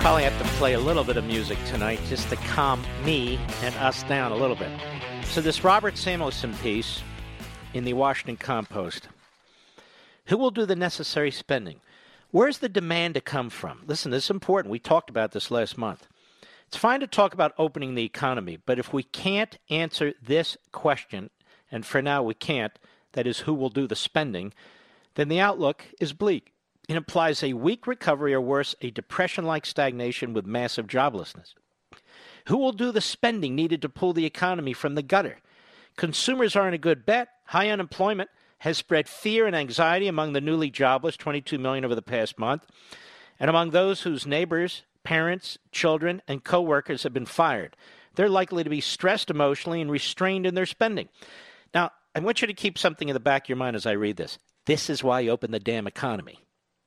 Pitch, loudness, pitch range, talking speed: 155 Hz, -26 LUFS, 130-190 Hz, 190 wpm